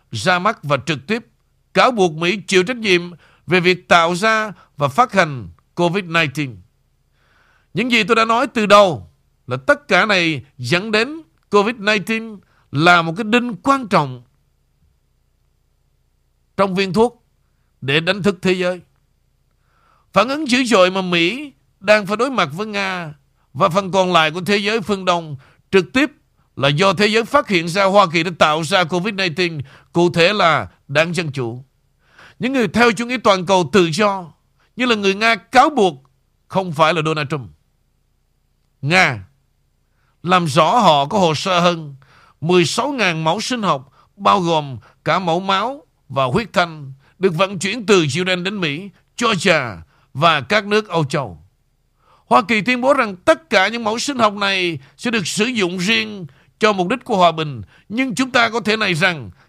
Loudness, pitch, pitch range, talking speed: -16 LUFS, 185 Hz, 150-215 Hz, 175 wpm